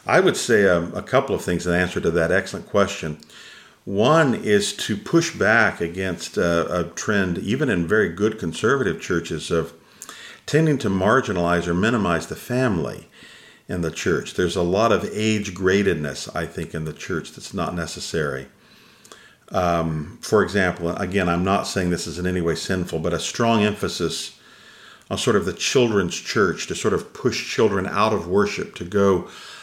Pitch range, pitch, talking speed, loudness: 85-100 Hz, 90 Hz, 175 wpm, -22 LUFS